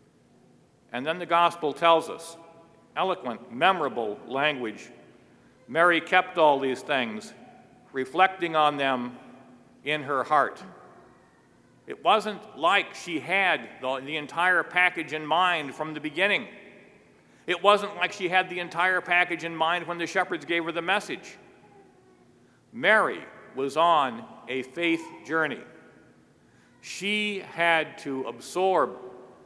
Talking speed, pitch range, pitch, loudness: 120 wpm, 145-180 Hz, 165 Hz, -25 LUFS